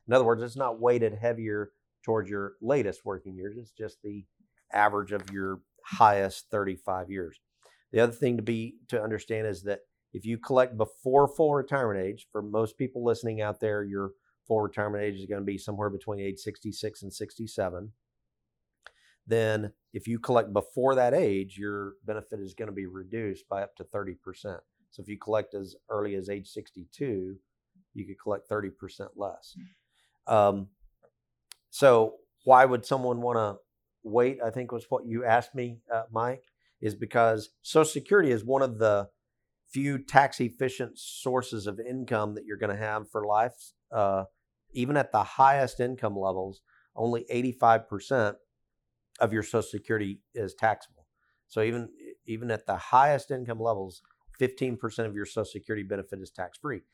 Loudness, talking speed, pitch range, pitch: -29 LUFS, 170 wpm, 100-120 Hz, 110 Hz